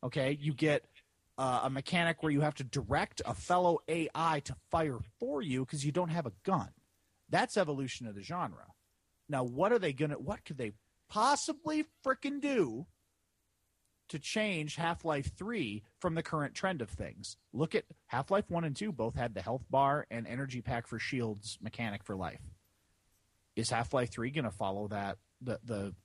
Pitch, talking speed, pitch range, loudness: 130 Hz, 185 wpm, 105-160 Hz, -35 LUFS